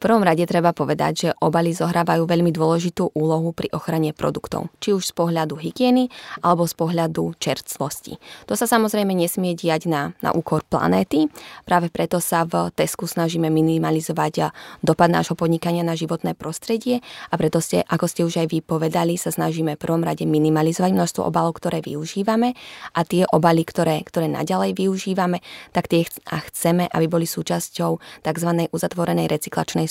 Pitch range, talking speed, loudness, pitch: 160-175 Hz, 160 wpm, -21 LUFS, 170 Hz